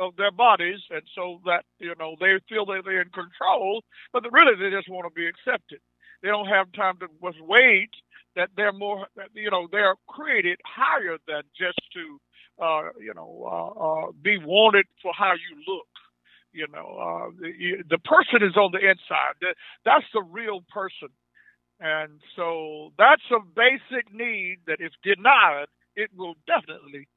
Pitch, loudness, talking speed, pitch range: 190 Hz, -22 LUFS, 170 wpm, 170-215 Hz